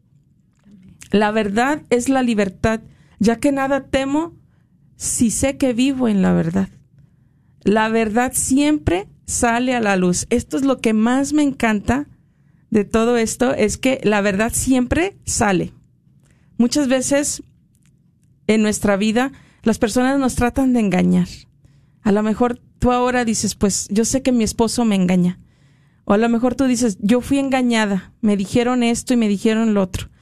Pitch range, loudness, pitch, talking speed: 200-255 Hz, -18 LUFS, 230 Hz, 160 wpm